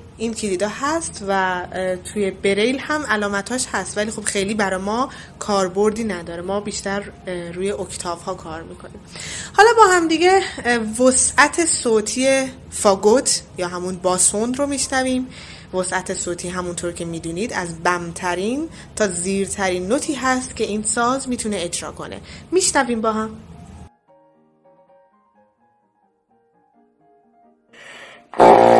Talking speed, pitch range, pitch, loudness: 115 wpm, 180-240 Hz, 200 Hz, -19 LUFS